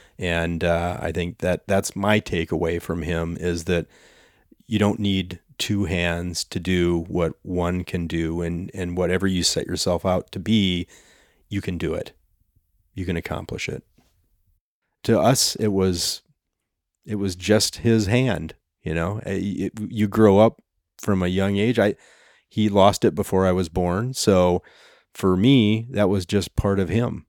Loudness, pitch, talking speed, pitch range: -22 LUFS, 95 Hz, 170 wpm, 85-100 Hz